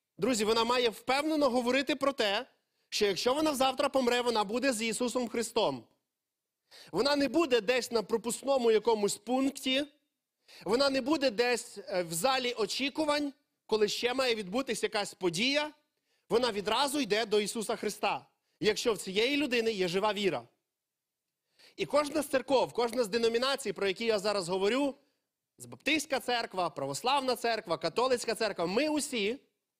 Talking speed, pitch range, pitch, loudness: 145 wpm, 215-270 Hz, 240 Hz, -30 LUFS